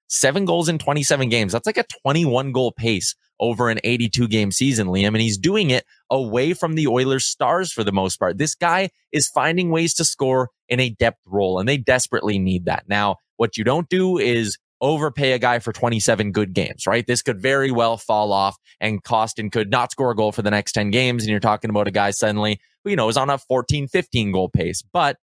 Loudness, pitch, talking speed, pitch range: -20 LUFS, 120 Hz, 230 wpm, 105-140 Hz